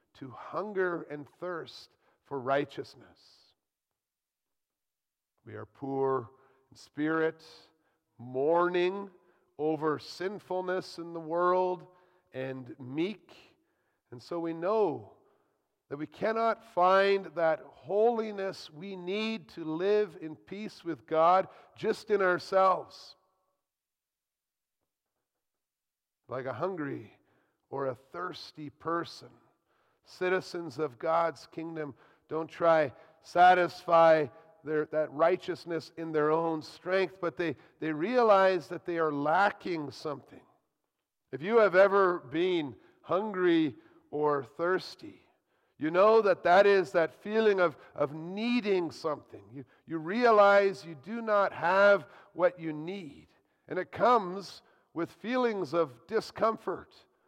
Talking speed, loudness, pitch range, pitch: 110 wpm, -29 LUFS, 155-195 Hz, 175 Hz